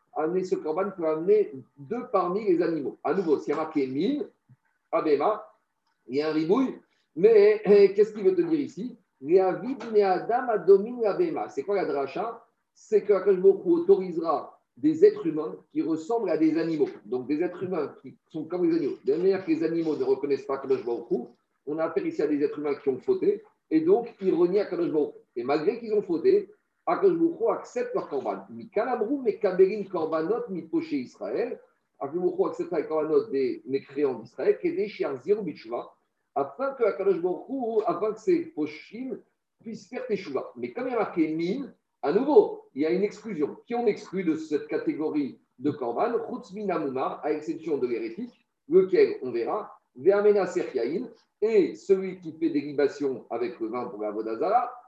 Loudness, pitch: -26 LUFS, 310 Hz